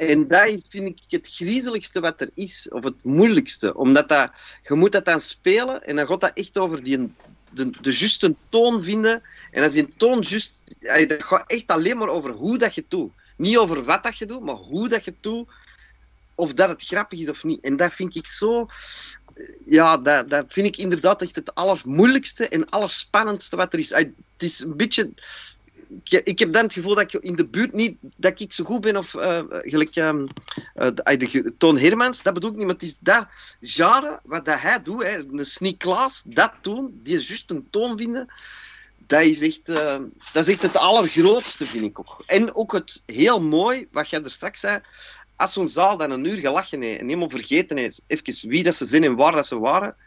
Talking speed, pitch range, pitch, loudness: 215 wpm, 160-230 Hz, 190 Hz, -20 LUFS